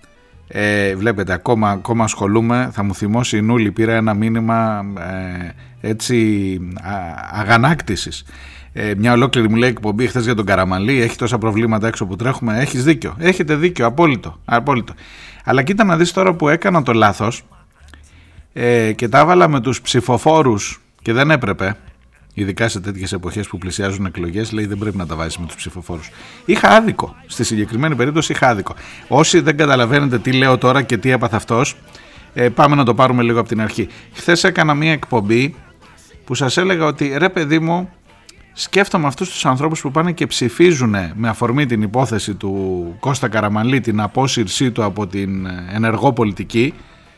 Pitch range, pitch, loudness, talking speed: 100-135 Hz, 115 Hz, -16 LUFS, 170 wpm